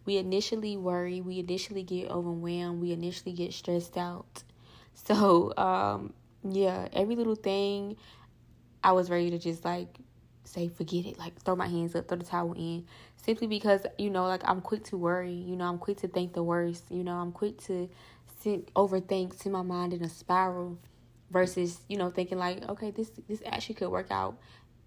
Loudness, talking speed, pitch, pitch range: -32 LUFS, 190 wpm, 180 Hz, 175-195 Hz